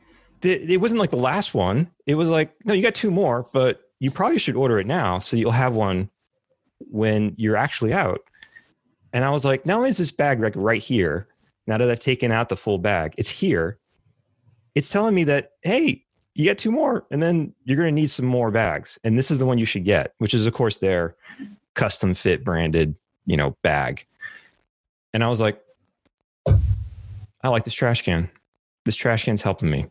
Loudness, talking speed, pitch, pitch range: -22 LUFS, 205 wpm, 120 Hz, 105-155 Hz